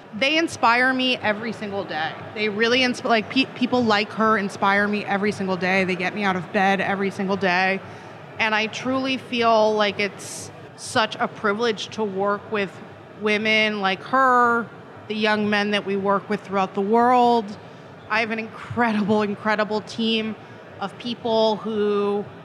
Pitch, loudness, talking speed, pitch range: 210 Hz, -21 LUFS, 165 wpm, 195-225 Hz